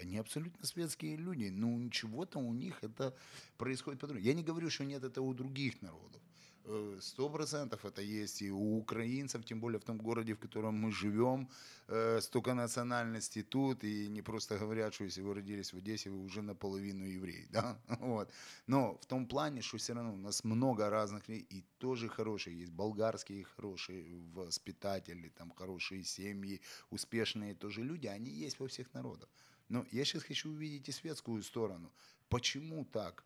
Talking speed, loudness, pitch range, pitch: 170 wpm, -41 LUFS, 100-130 Hz, 110 Hz